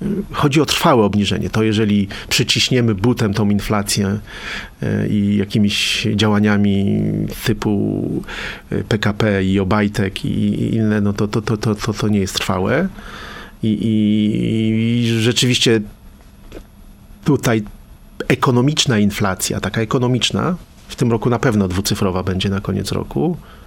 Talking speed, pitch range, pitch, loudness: 120 wpm, 100-115 Hz, 105 Hz, -17 LUFS